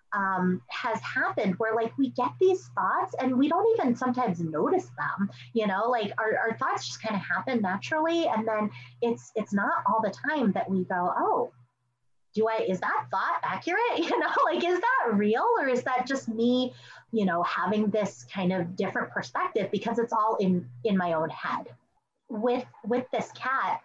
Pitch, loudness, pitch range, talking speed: 220 Hz, -28 LUFS, 190-250 Hz, 190 wpm